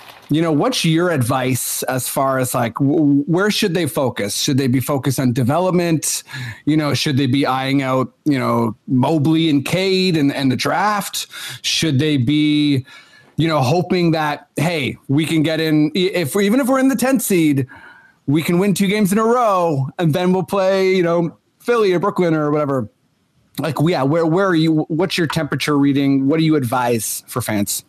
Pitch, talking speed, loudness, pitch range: 150 Hz, 195 wpm, -17 LUFS, 135-175 Hz